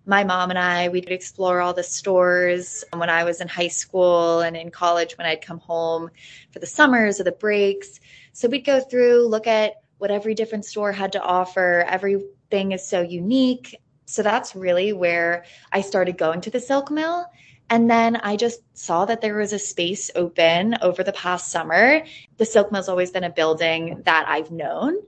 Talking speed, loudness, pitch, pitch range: 195 wpm, -21 LUFS, 185 Hz, 175-215 Hz